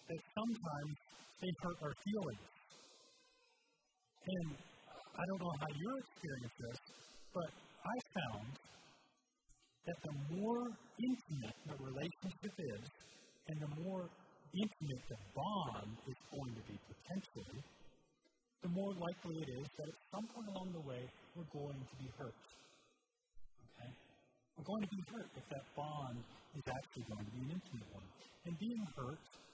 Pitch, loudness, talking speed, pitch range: 155 Hz, -47 LUFS, 145 wpm, 130-190 Hz